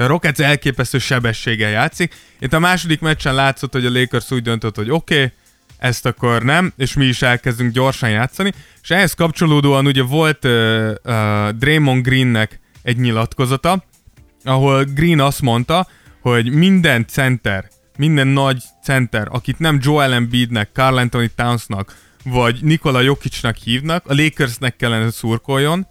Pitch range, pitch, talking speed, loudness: 120-150 Hz, 130 Hz, 145 wpm, -16 LUFS